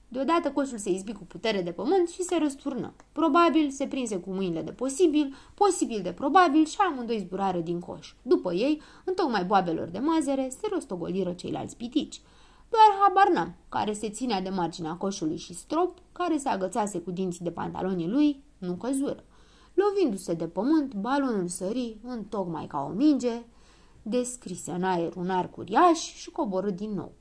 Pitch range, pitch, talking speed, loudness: 185-310 Hz, 240 Hz, 170 wpm, -27 LUFS